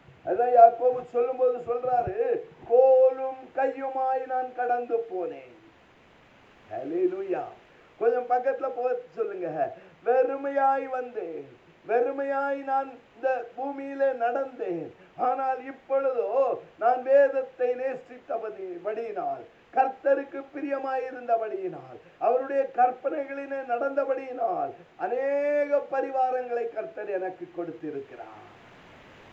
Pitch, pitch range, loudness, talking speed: 260 Hz, 245-275 Hz, -27 LUFS, 75 wpm